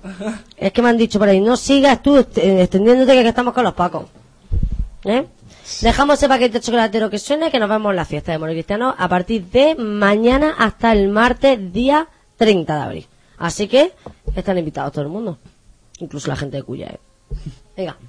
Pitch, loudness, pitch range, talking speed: 210 Hz, -16 LUFS, 170-245 Hz, 200 wpm